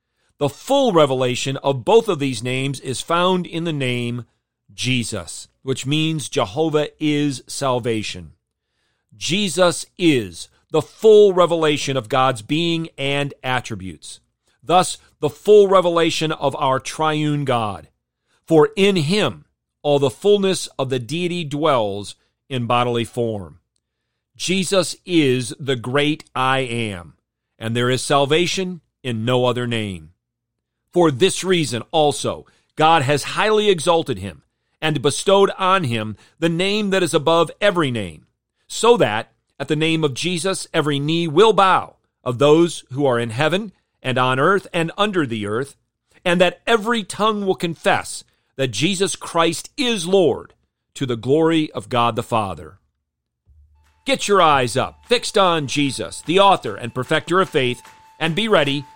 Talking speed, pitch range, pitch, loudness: 145 wpm, 120-175 Hz, 145 Hz, -19 LUFS